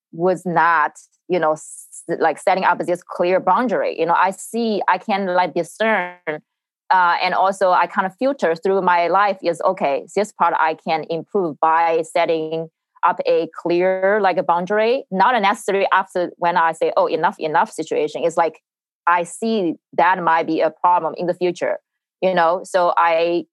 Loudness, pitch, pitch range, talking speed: -19 LUFS, 180 Hz, 170-200 Hz, 180 wpm